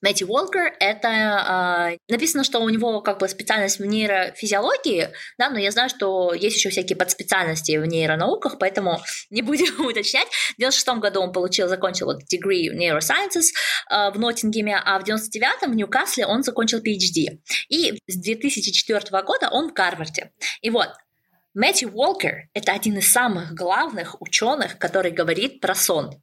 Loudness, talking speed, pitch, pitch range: -21 LUFS, 165 wpm, 210 Hz, 190-250 Hz